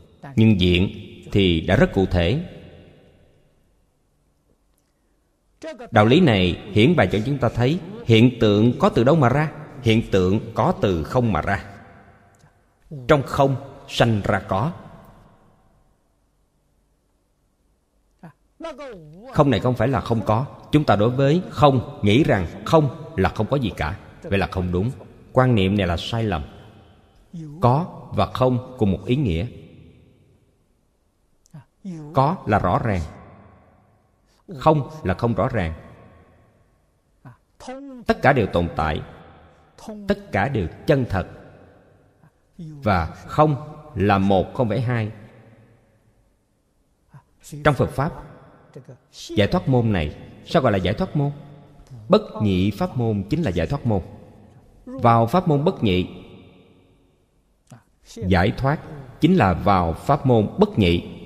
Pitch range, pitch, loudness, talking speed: 95-140 Hz, 110 Hz, -20 LUFS, 130 wpm